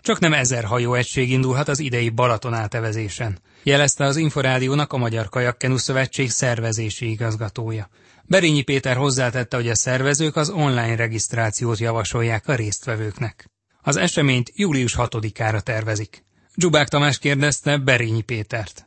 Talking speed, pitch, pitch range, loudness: 130 wpm, 125 Hz, 115-140 Hz, -20 LUFS